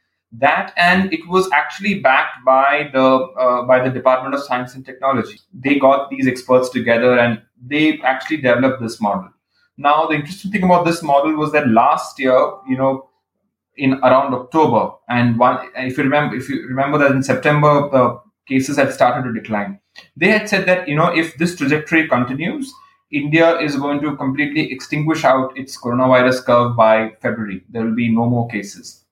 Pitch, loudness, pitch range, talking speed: 135 Hz, -16 LUFS, 125-155 Hz, 180 wpm